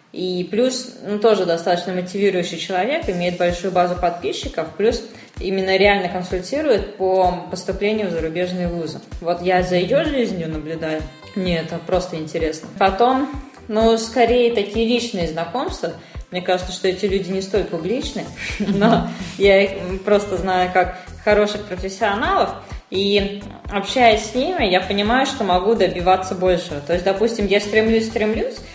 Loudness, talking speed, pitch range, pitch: -19 LUFS, 140 wpm, 180-215 Hz, 190 Hz